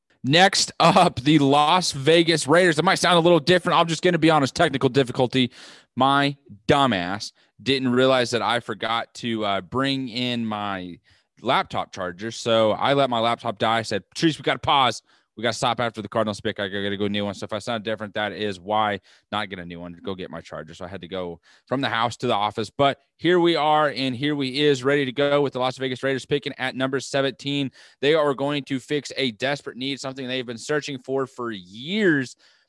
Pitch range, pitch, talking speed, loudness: 110-145 Hz, 130 Hz, 230 wpm, -22 LUFS